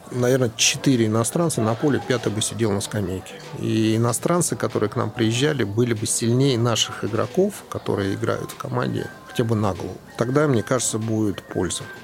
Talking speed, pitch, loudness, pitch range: 165 wpm, 115 Hz, -22 LUFS, 110-130 Hz